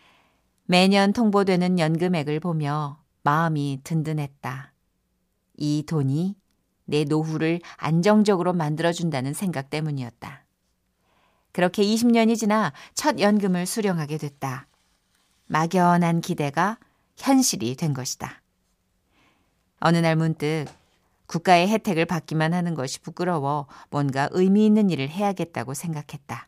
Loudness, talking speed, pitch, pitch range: -23 LUFS, 255 characters per minute, 165 Hz, 145-185 Hz